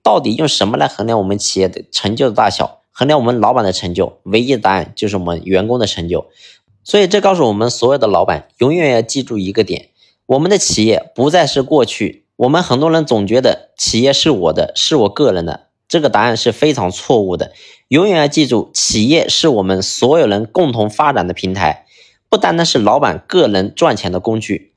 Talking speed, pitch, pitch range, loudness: 320 characters per minute, 115 Hz, 100-140 Hz, -13 LUFS